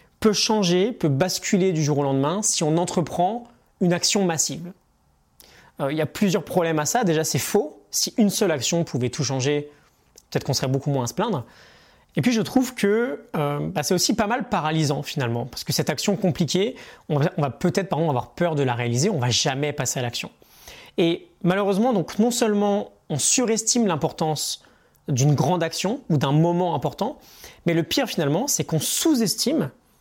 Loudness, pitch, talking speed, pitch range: -22 LUFS, 165 Hz, 195 wpm, 145-205 Hz